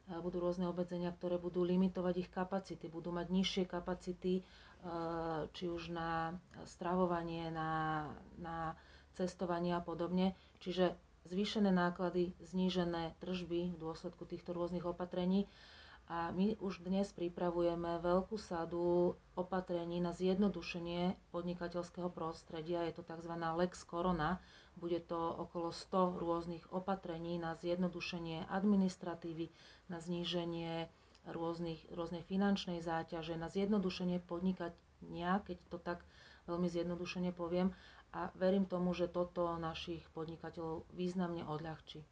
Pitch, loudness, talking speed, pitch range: 175 Hz, -40 LUFS, 115 wpm, 170-180 Hz